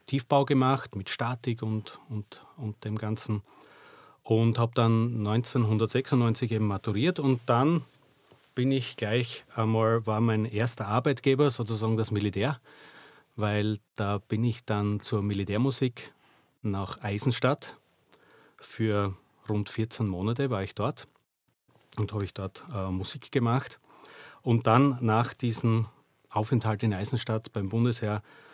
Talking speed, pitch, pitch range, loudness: 125 wpm, 115 Hz, 105-130 Hz, -28 LUFS